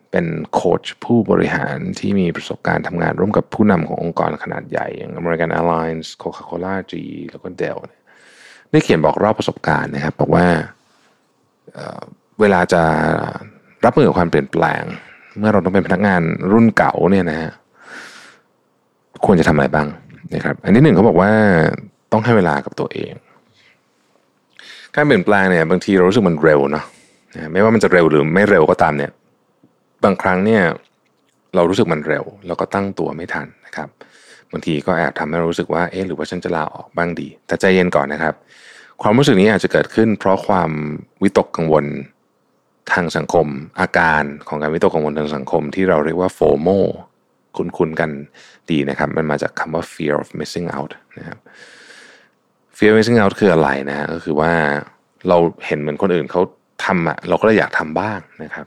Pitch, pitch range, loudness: 85 Hz, 75-95 Hz, -16 LUFS